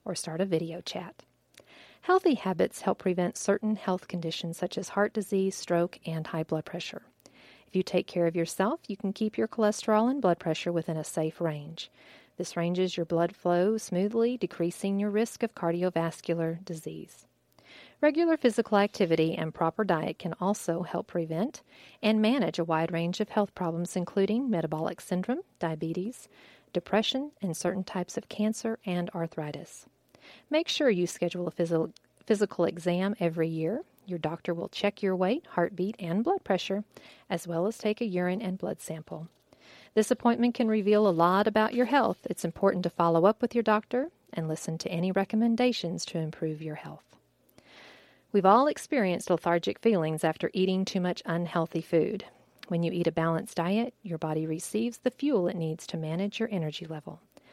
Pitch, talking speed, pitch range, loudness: 180 Hz, 170 wpm, 170-215 Hz, -29 LUFS